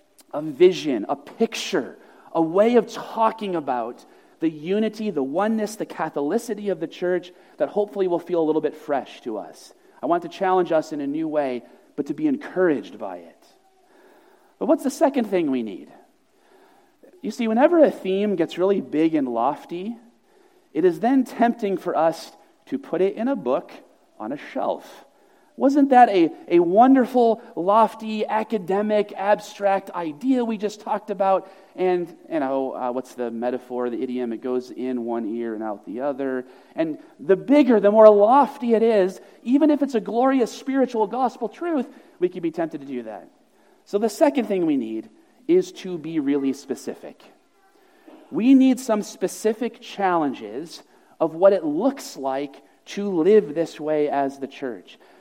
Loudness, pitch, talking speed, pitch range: -22 LUFS, 215 Hz, 170 wpm, 165-275 Hz